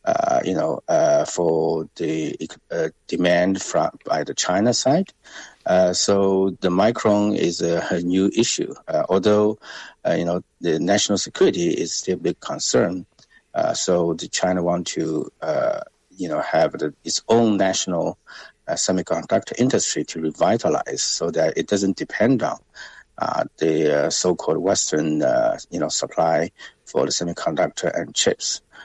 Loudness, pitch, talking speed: -21 LUFS, 100 Hz, 155 wpm